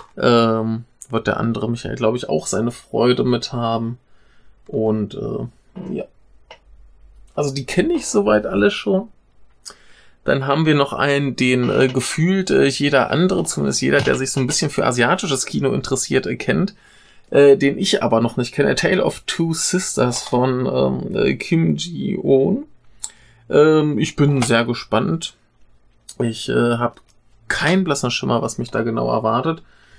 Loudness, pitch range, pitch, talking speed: -18 LUFS, 115-145 Hz, 125 Hz, 155 wpm